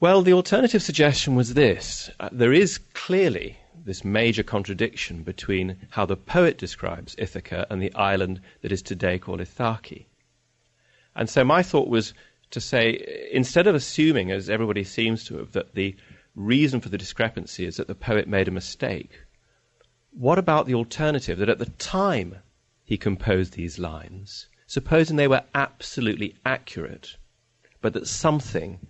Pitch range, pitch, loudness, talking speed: 95-140 Hz, 110 Hz, -23 LUFS, 155 wpm